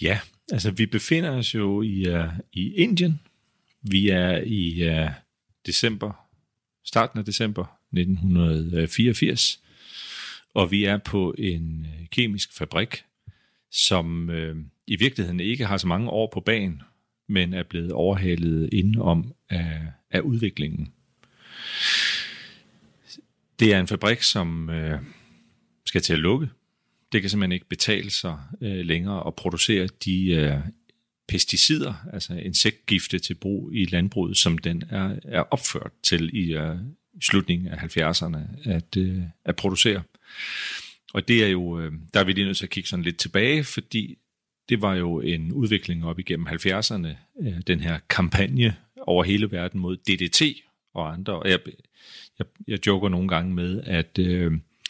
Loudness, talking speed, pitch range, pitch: -24 LUFS, 150 wpm, 85-105 Hz, 95 Hz